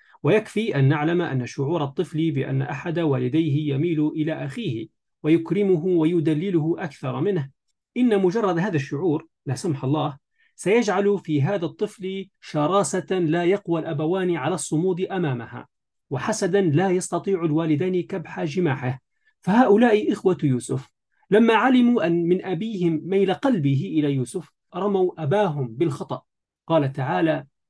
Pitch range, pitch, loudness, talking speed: 150-190 Hz, 170 Hz, -23 LUFS, 125 wpm